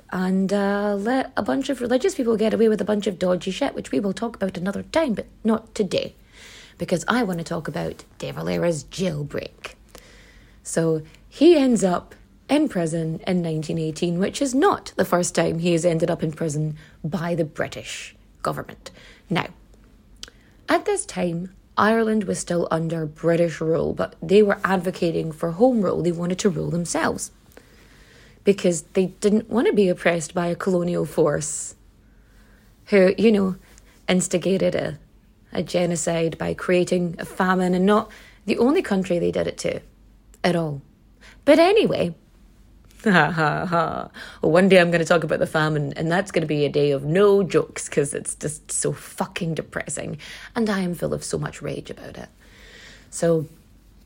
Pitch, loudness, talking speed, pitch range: 180 Hz, -22 LUFS, 170 wpm, 165-205 Hz